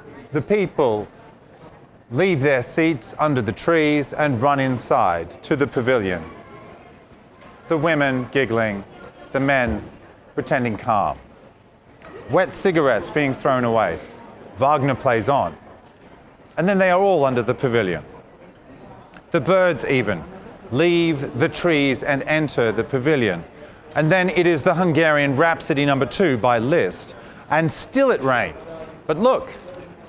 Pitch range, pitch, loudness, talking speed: 135-165 Hz, 150 Hz, -20 LUFS, 130 wpm